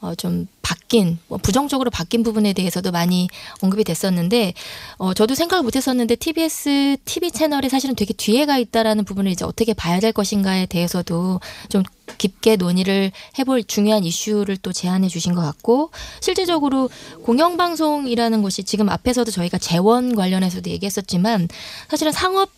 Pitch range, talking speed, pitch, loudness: 185-260 Hz, 375 characters per minute, 215 Hz, -19 LUFS